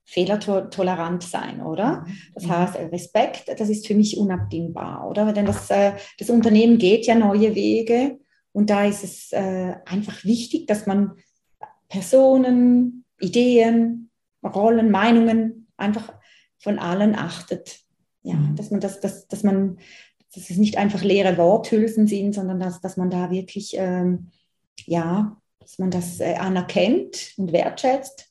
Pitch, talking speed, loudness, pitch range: 200 Hz, 130 wpm, -21 LUFS, 185-225 Hz